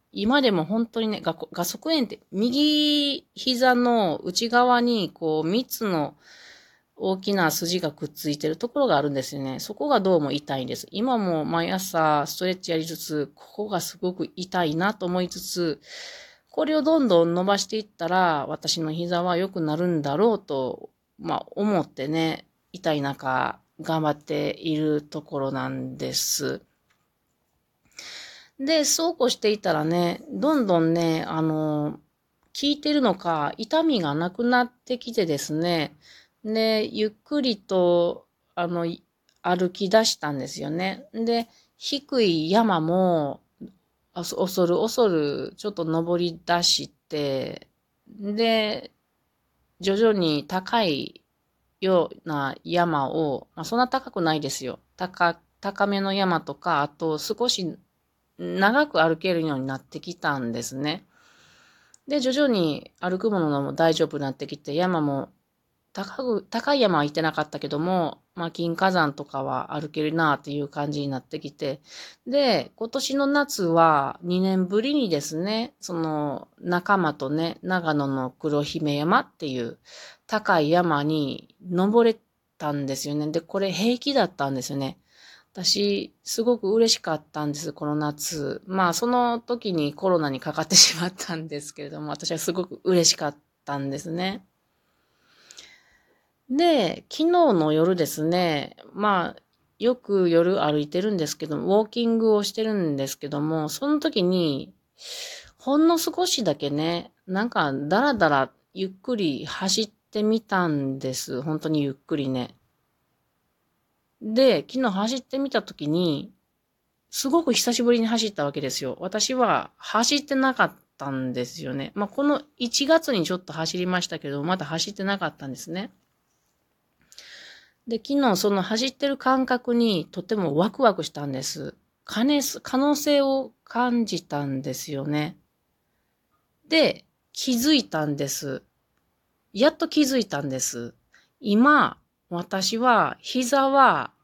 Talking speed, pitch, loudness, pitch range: 265 characters per minute, 180 Hz, -24 LUFS, 155-230 Hz